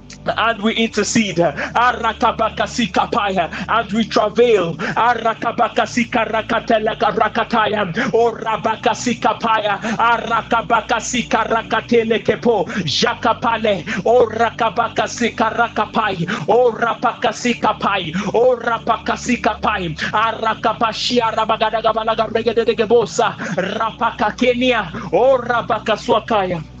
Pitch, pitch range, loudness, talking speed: 225 Hz, 220-235 Hz, -17 LUFS, 65 wpm